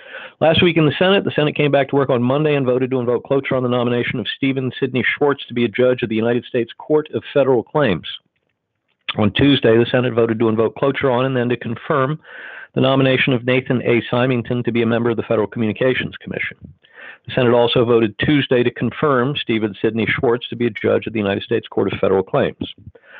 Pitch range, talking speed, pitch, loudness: 115-135 Hz, 225 wpm, 125 Hz, -18 LUFS